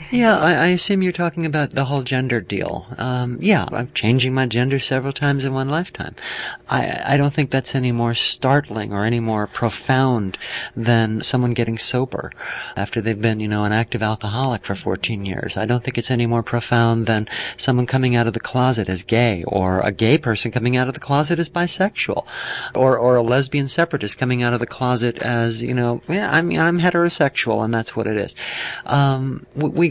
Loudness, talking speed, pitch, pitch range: -19 LUFS, 215 wpm, 125 Hz, 115-140 Hz